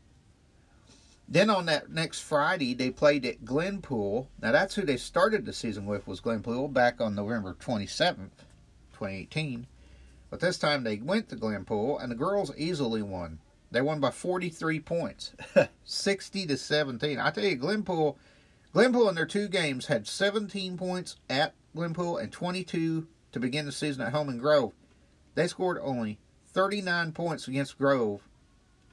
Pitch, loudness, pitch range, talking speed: 150 Hz, -29 LUFS, 120-185 Hz, 165 wpm